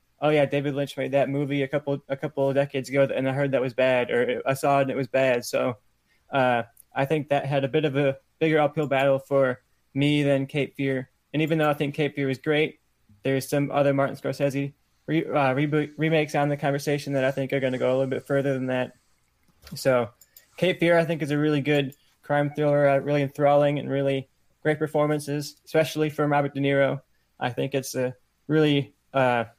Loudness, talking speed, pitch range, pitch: -25 LUFS, 220 wpm, 135-145 Hz, 140 Hz